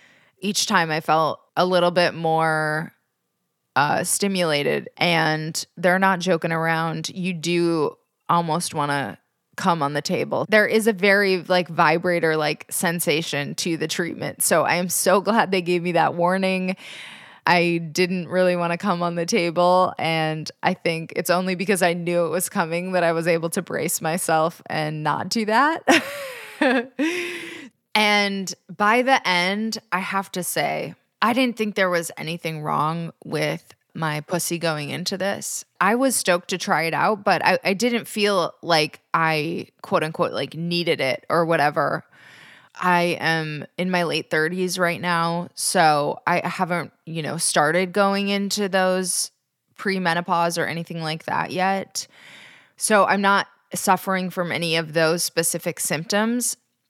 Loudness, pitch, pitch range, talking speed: -21 LUFS, 175 Hz, 165-195 Hz, 160 wpm